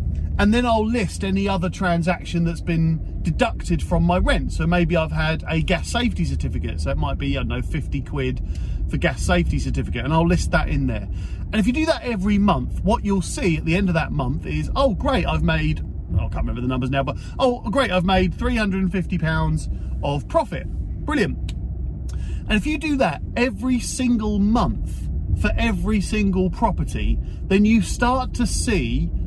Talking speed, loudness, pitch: 195 wpm, -22 LUFS, 160 Hz